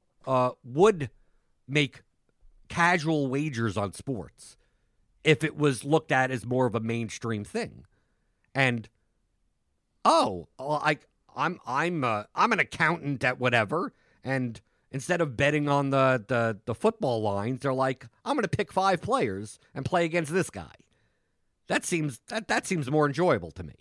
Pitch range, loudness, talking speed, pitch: 115-155 Hz, -27 LUFS, 150 wpm, 135 Hz